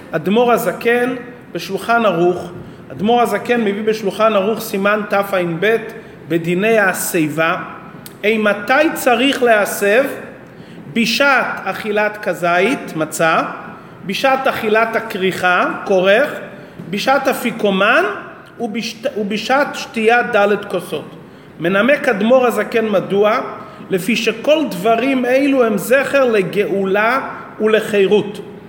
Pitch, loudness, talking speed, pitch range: 210 Hz, -15 LUFS, 90 wpm, 190-235 Hz